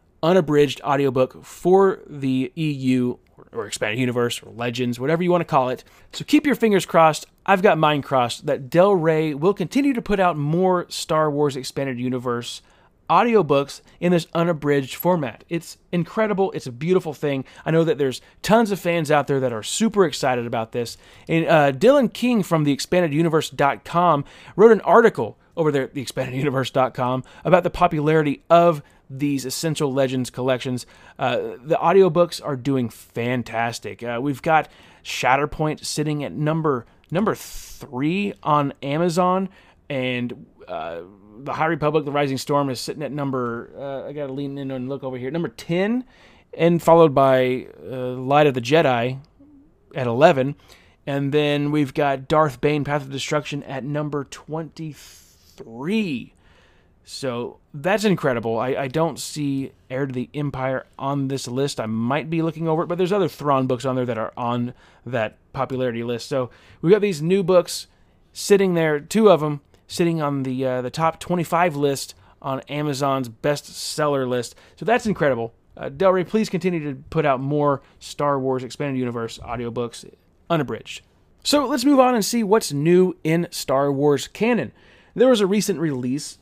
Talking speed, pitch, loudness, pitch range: 170 wpm, 145 Hz, -21 LUFS, 130-170 Hz